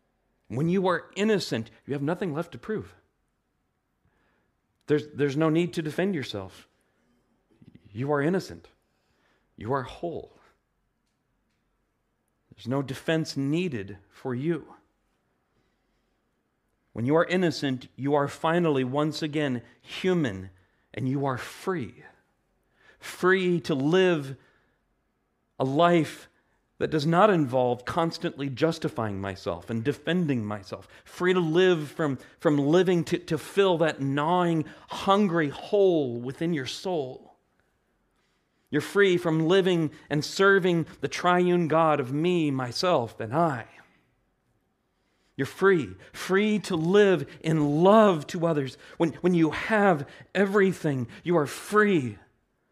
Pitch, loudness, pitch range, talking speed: 155 Hz, -26 LUFS, 130-175 Hz, 120 wpm